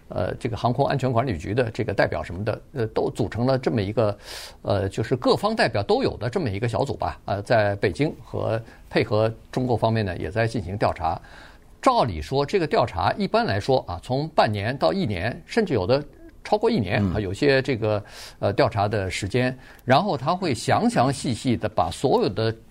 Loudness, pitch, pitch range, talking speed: -24 LUFS, 115 Hz, 105-130 Hz, 300 characters per minute